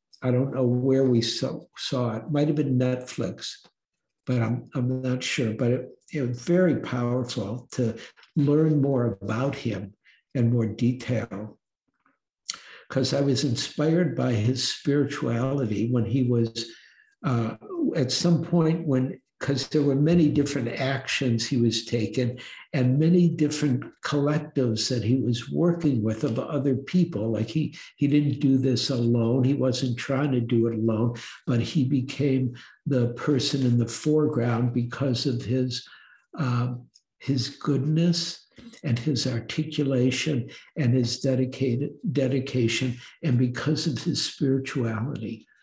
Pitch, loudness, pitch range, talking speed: 130 Hz, -25 LUFS, 120-145 Hz, 140 wpm